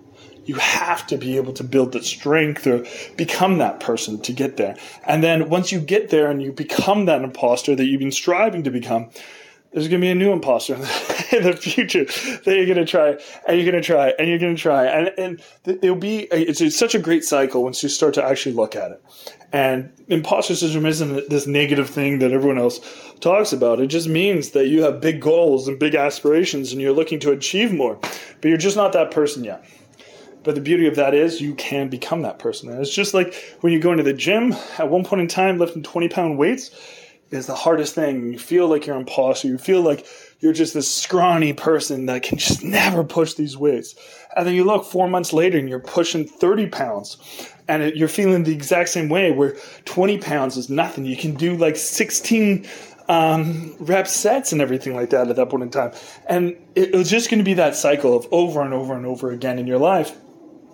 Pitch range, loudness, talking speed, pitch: 140-180 Hz, -19 LUFS, 225 wpm, 160 Hz